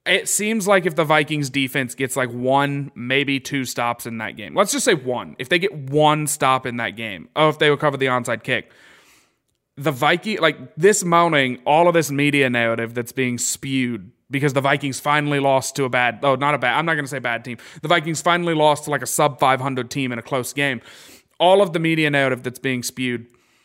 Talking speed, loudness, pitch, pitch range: 225 wpm, -19 LUFS, 140 Hz, 125-155 Hz